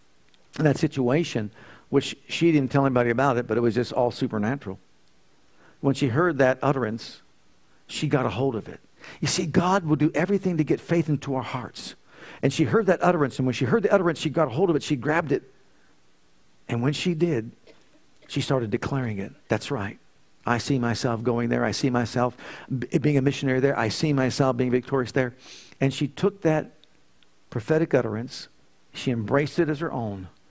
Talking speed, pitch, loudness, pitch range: 195 wpm, 135 Hz, -25 LUFS, 120-155 Hz